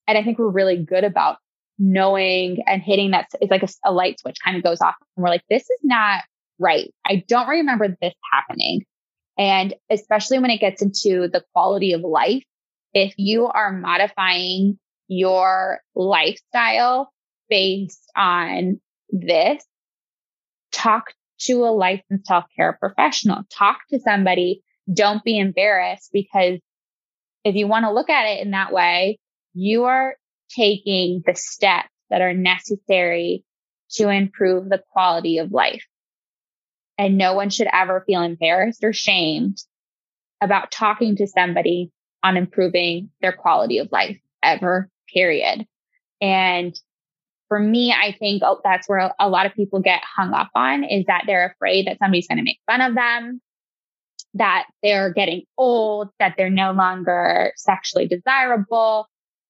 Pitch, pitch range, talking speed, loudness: 195 Hz, 185-215 Hz, 150 wpm, -19 LUFS